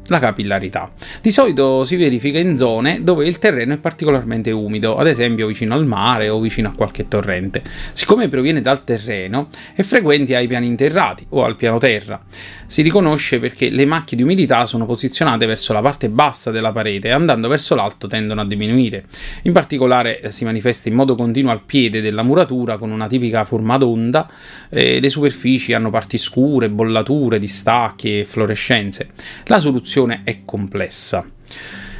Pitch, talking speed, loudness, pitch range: 120 Hz, 165 wpm, -16 LUFS, 110-140 Hz